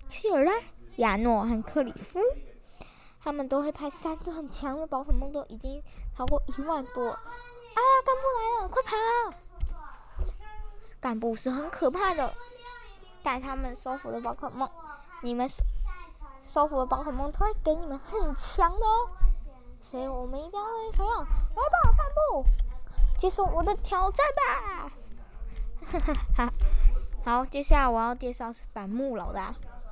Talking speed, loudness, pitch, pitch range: 215 characters per minute, -29 LUFS, 295 Hz, 260-405 Hz